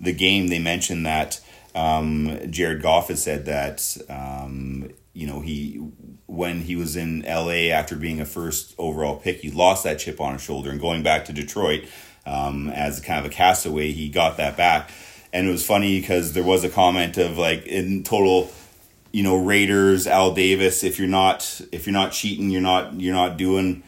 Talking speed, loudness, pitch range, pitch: 195 wpm, -21 LUFS, 75-95 Hz, 85 Hz